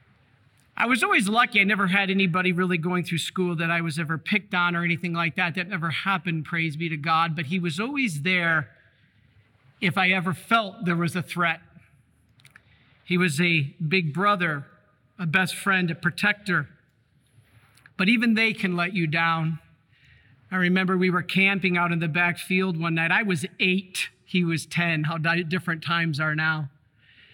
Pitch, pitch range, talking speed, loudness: 170 Hz, 155-185 Hz, 180 wpm, -24 LUFS